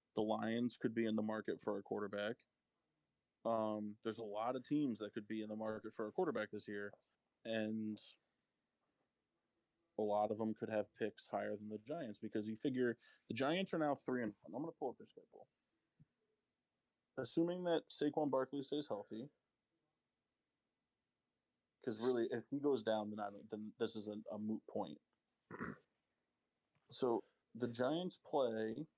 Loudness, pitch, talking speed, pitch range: -43 LUFS, 110 Hz, 170 wpm, 105-130 Hz